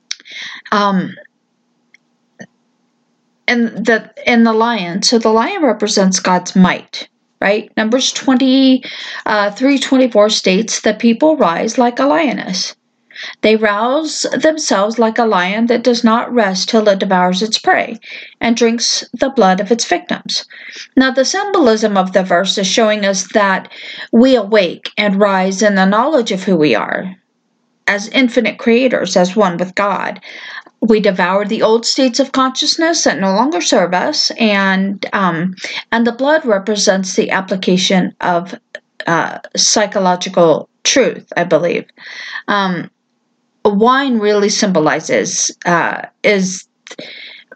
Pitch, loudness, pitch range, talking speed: 220 Hz, -13 LUFS, 195-255 Hz, 135 wpm